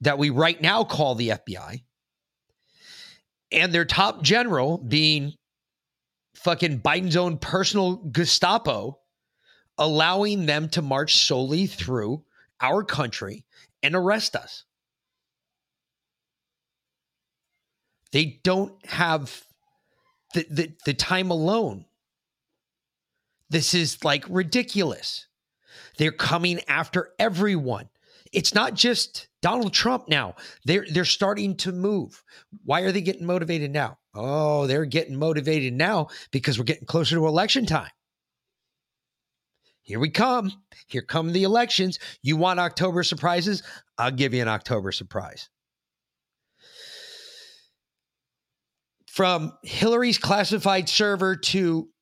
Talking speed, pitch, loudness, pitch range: 110 wpm, 170 Hz, -23 LUFS, 145-195 Hz